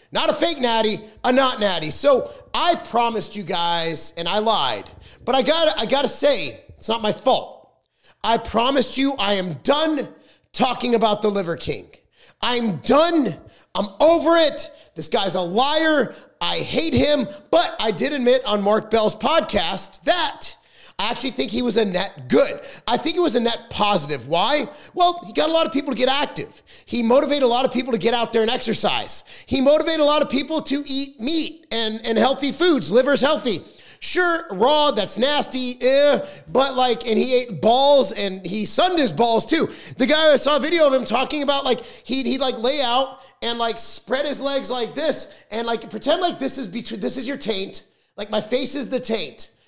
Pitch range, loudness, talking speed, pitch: 220-285 Hz, -20 LUFS, 200 wpm, 255 Hz